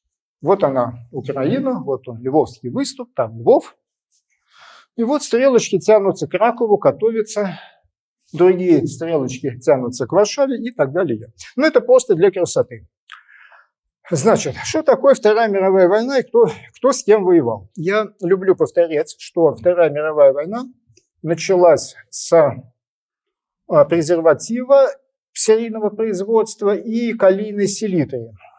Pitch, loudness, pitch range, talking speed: 205 Hz, -17 LUFS, 160-250 Hz, 120 wpm